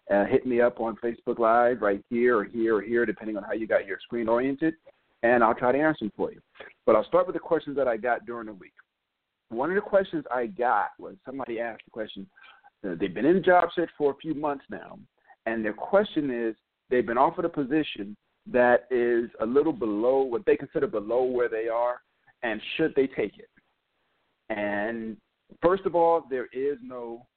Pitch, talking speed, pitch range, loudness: 125 Hz, 215 wpm, 115-155 Hz, -26 LUFS